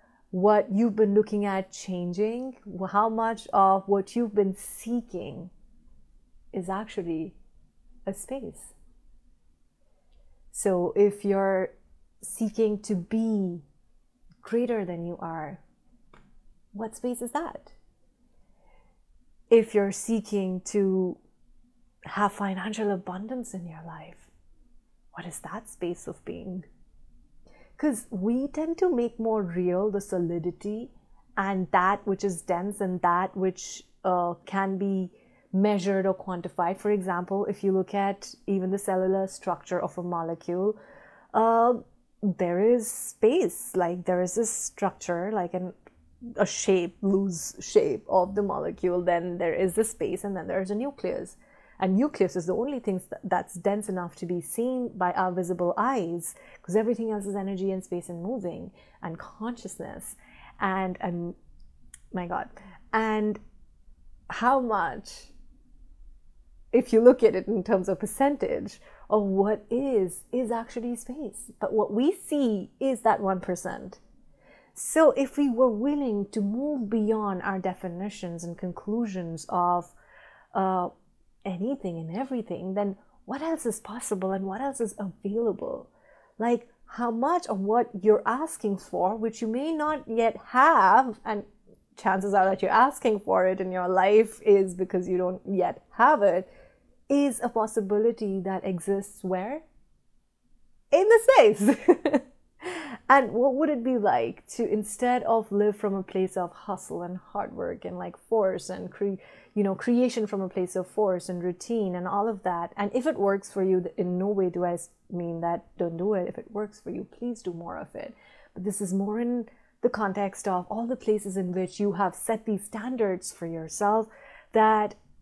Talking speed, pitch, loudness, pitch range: 155 wpm, 200 Hz, -27 LUFS, 185-230 Hz